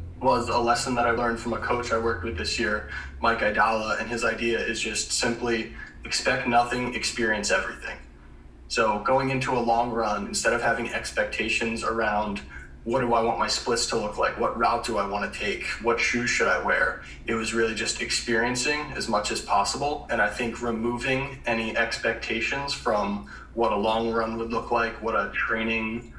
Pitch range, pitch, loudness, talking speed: 110-120 Hz, 115 Hz, -25 LUFS, 190 wpm